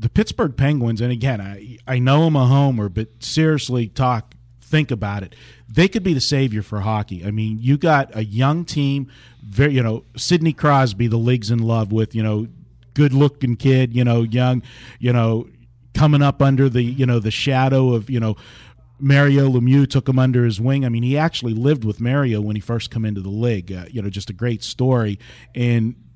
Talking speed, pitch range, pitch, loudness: 210 wpm, 115-135 Hz, 120 Hz, -18 LUFS